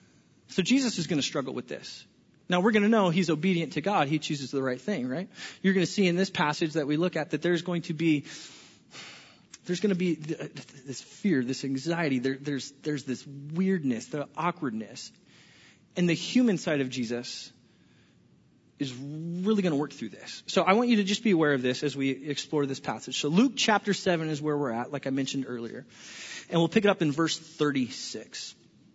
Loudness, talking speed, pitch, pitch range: -28 LUFS, 210 wpm, 160 Hz, 140-185 Hz